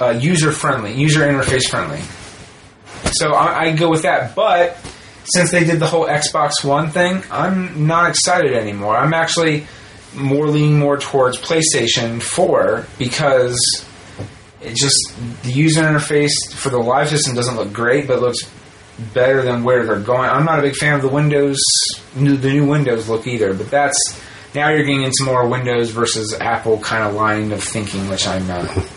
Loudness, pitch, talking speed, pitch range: -16 LUFS, 135 Hz, 170 wpm, 115-150 Hz